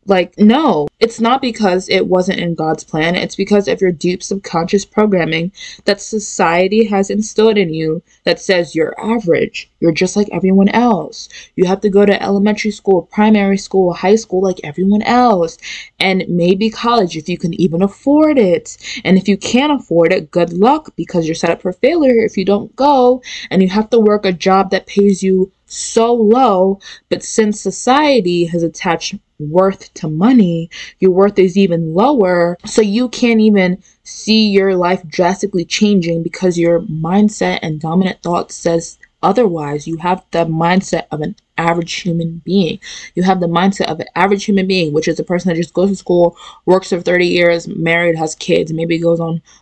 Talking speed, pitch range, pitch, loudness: 185 wpm, 170-210 Hz, 190 Hz, -14 LUFS